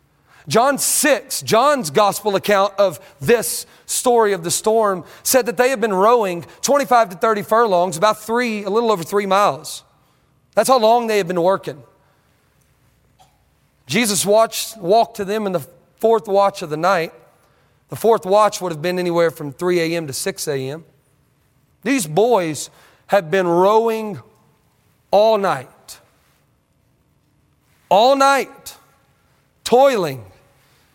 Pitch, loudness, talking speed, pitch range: 200 Hz, -17 LUFS, 135 wpm, 175-225 Hz